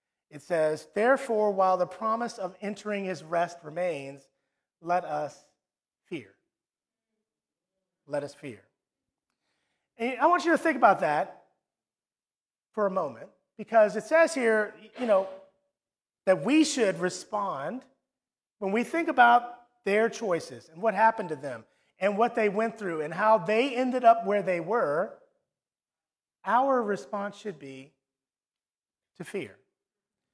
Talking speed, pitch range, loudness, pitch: 135 wpm, 180-235 Hz, -27 LUFS, 210 Hz